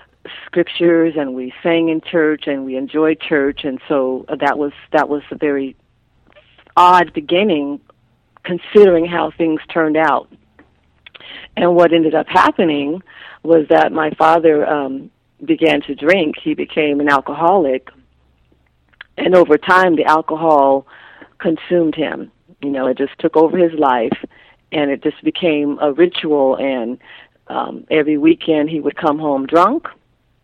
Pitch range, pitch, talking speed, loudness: 140-165 Hz, 155 Hz, 140 wpm, -15 LUFS